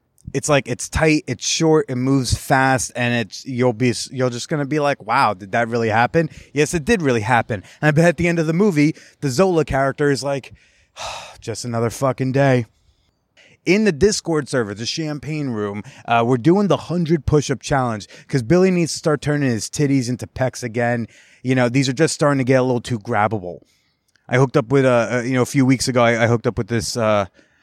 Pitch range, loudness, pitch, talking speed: 120-150 Hz, -19 LUFS, 130 Hz, 215 wpm